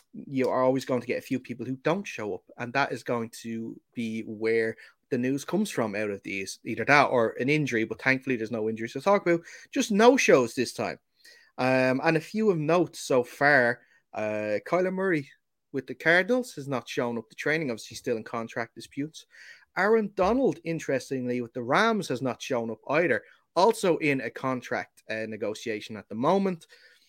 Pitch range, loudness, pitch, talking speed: 115-175 Hz, -27 LUFS, 130 Hz, 200 wpm